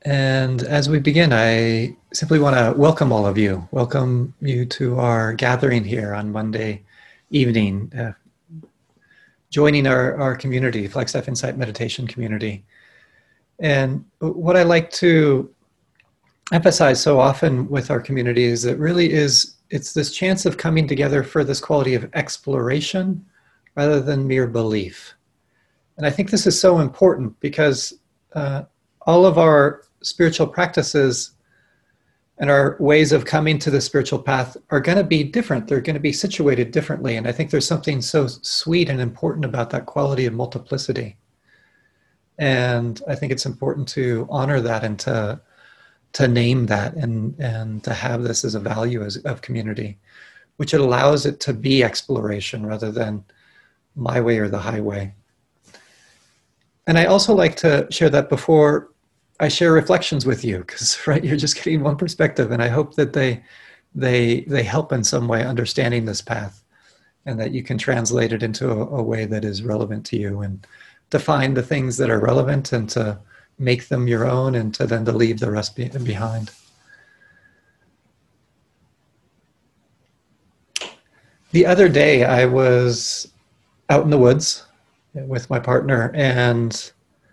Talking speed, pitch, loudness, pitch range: 160 wpm, 130 Hz, -19 LUFS, 115-150 Hz